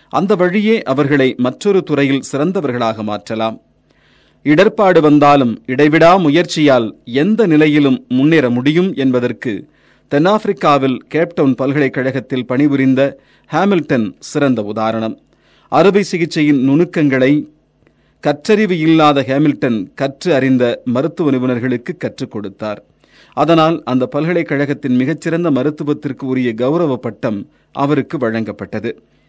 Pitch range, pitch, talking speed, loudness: 125-160 Hz, 145 Hz, 90 wpm, -14 LUFS